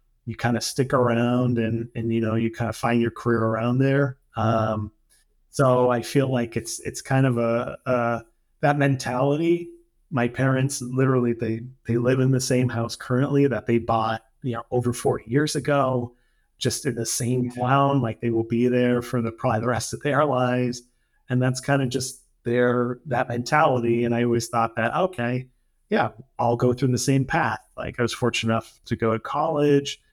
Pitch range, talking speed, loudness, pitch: 115-135 Hz, 195 wpm, -23 LUFS, 125 Hz